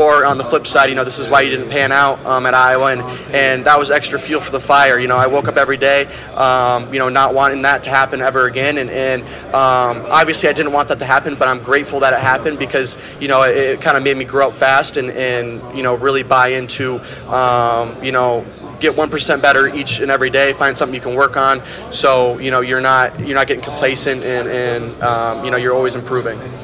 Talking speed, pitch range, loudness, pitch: 250 wpm, 125-140 Hz, -14 LUFS, 130 Hz